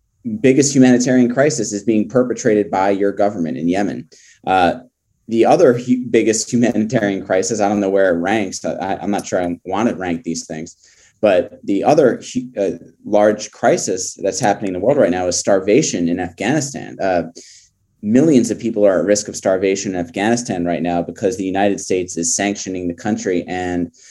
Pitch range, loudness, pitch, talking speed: 90-115 Hz, -17 LUFS, 100 Hz, 185 wpm